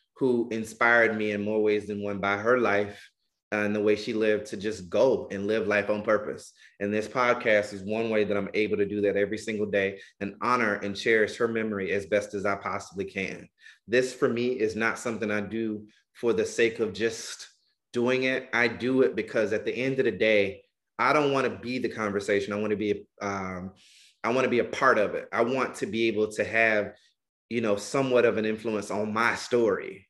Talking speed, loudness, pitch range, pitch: 225 wpm, -27 LUFS, 100-115 Hz, 105 Hz